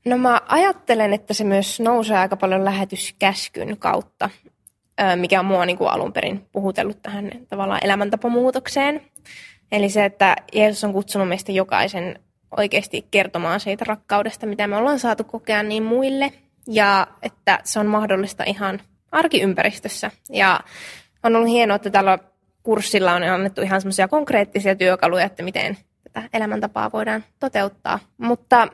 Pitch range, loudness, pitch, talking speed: 195-225 Hz, -20 LUFS, 205 Hz, 140 wpm